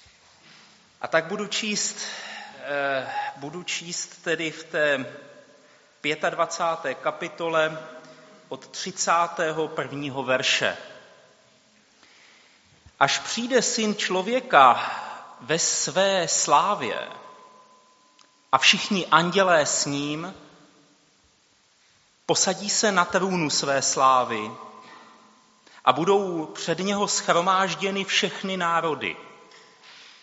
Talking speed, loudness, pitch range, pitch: 75 wpm, -23 LUFS, 155-200 Hz, 170 Hz